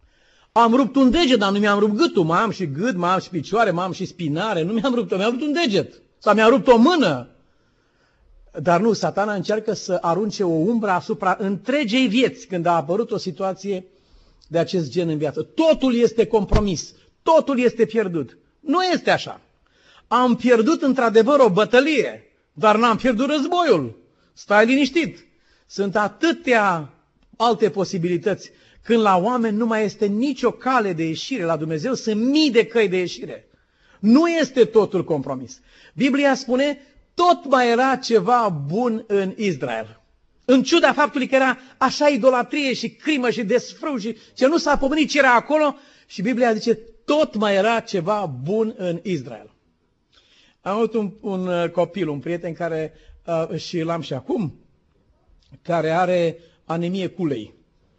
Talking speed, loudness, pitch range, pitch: 160 wpm, -20 LUFS, 180-255 Hz, 220 Hz